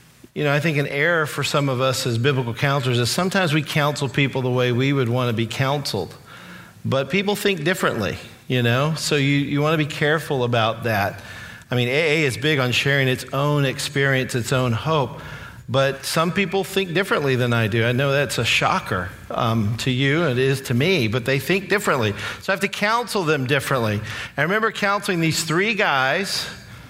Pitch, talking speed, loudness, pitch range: 140 Hz, 205 wpm, -20 LUFS, 125-160 Hz